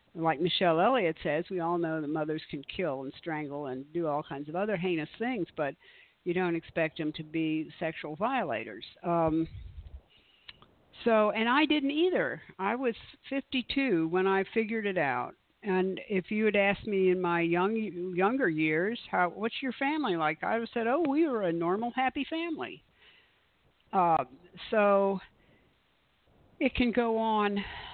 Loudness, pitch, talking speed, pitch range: -30 LUFS, 185 Hz, 165 wpm, 160-230 Hz